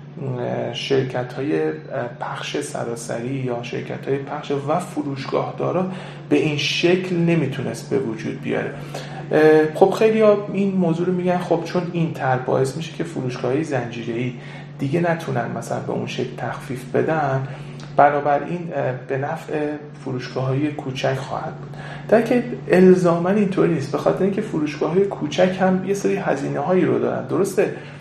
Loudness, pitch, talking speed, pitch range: -21 LUFS, 150 Hz, 150 wpm, 130-175 Hz